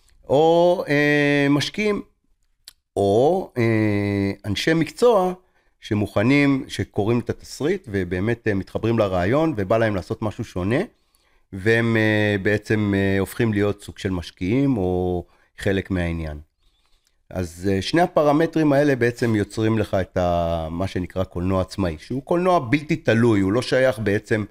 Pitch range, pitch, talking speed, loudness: 95-130 Hz, 105 Hz, 120 wpm, -21 LUFS